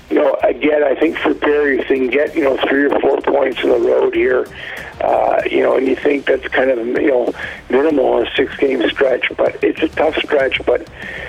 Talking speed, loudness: 235 wpm, -15 LUFS